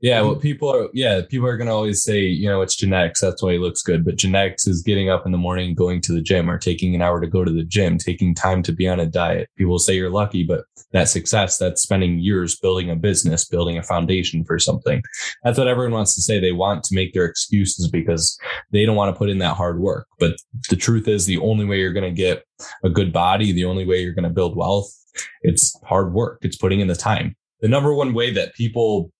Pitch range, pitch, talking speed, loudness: 90-105 Hz, 95 Hz, 255 wpm, -19 LUFS